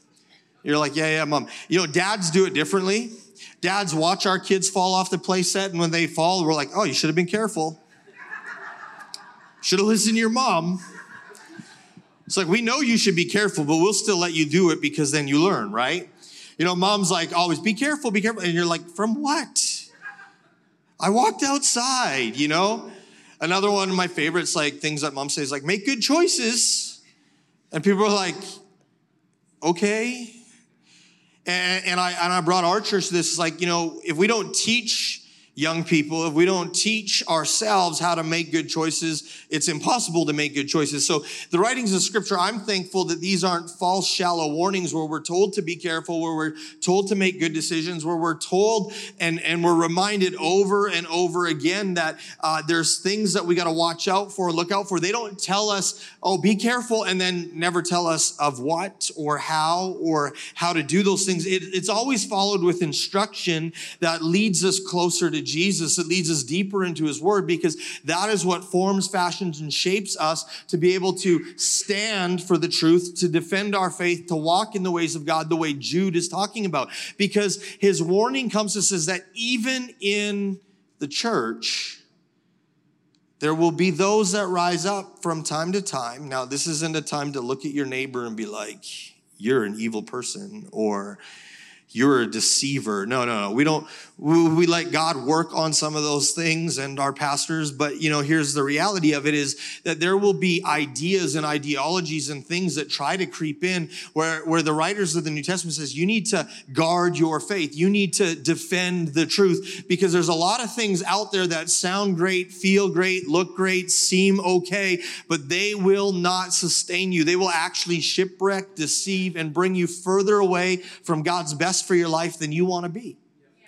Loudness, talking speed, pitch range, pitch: -22 LUFS, 195 wpm, 160-195 Hz, 175 Hz